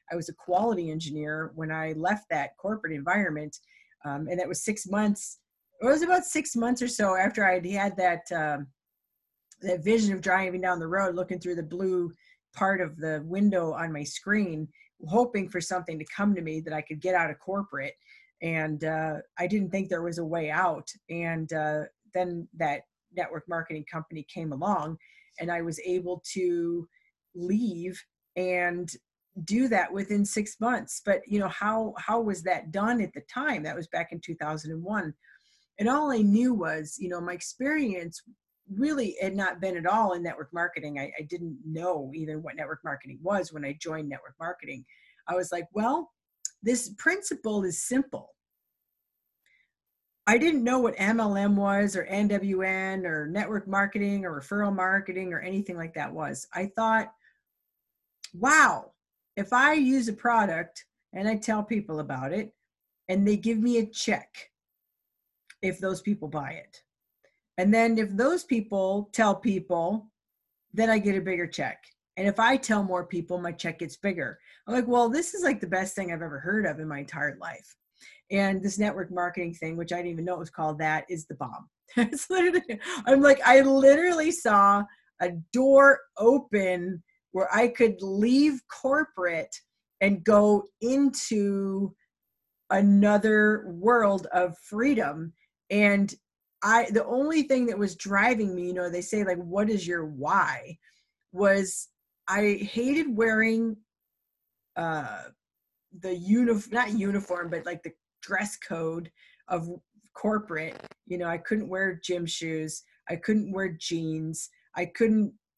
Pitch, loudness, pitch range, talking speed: 190 Hz, -27 LUFS, 170-220 Hz, 165 wpm